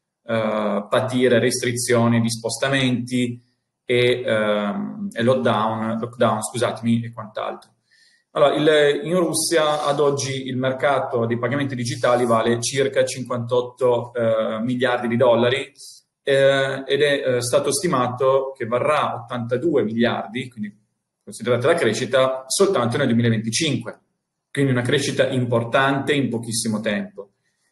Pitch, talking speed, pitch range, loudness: 125 Hz, 120 wpm, 115-135 Hz, -20 LUFS